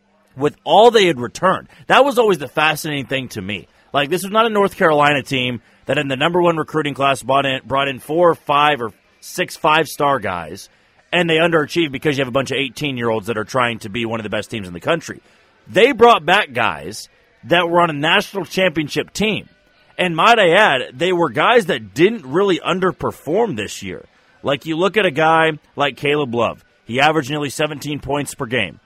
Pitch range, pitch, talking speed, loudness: 130-170 Hz, 145 Hz, 215 wpm, -17 LUFS